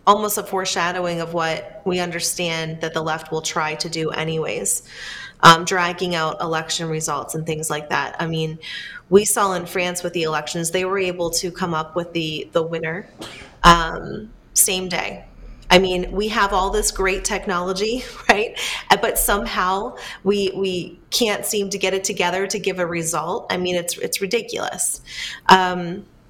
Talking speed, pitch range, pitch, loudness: 170 wpm, 165-195 Hz, 180 Hz, -20 LUFS